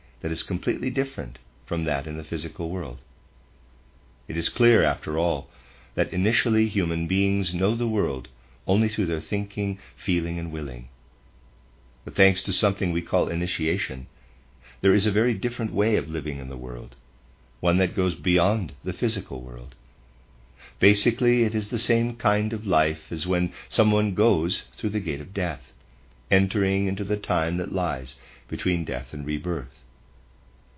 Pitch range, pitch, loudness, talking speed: 65-100 Hz, 85 Hz, -25 LUFS, 160 wpm